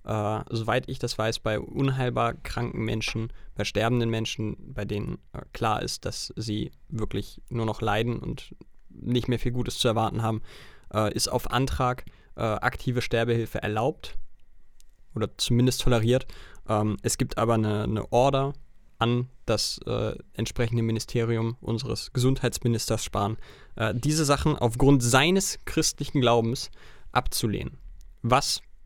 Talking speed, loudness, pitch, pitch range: 135 wpm, -27 LUFS, 115 Hz, 110-125 Hz